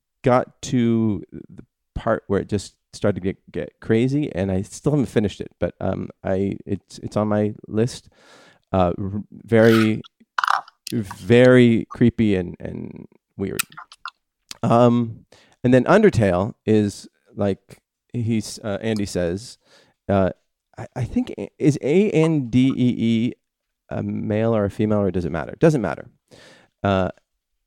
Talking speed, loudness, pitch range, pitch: 140 wpm, -21 LUFS, 100-120 Hz, 110 Hz